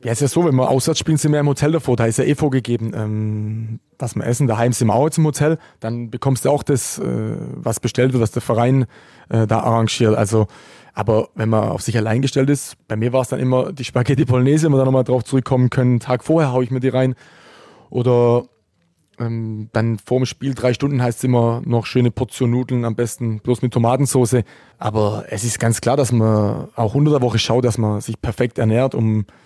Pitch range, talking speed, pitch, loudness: 115-130 Hz, 230 wpm, 125 Hz, -18 LUFS